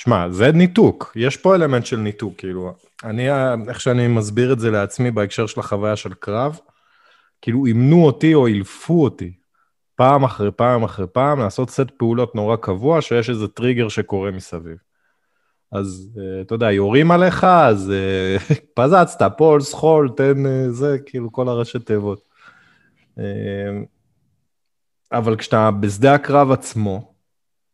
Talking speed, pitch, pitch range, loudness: 135 wpm, 120 Hz, 100-135 Hz, -17 LUFS